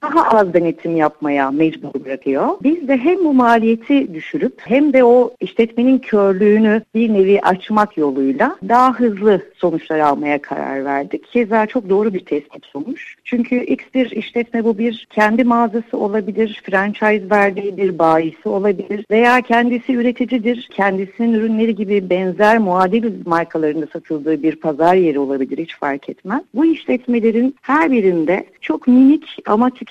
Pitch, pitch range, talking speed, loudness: 215 Hz, 170-245 Hz, 145 wpm, -16 LUFS